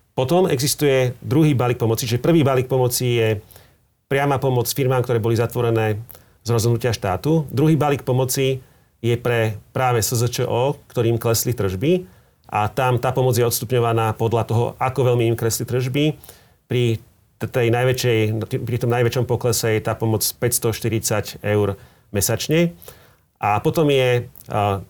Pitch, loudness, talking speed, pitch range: 120 Hz, -20 LUFS, 145 wpm, 115-130 Hz